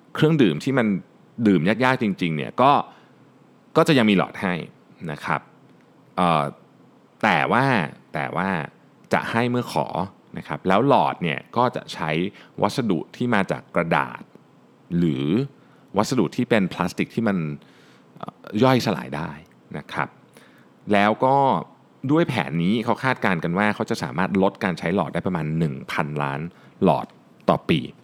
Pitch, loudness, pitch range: 100 Hz, -22 LUFS, 80-125 Hz